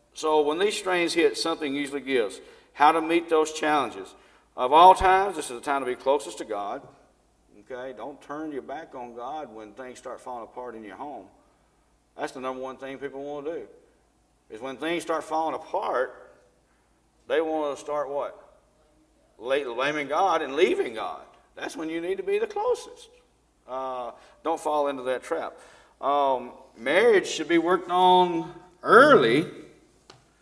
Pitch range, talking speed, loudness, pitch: 135-210 Hz, 170 wpm, -24 LUFS, 155 Hz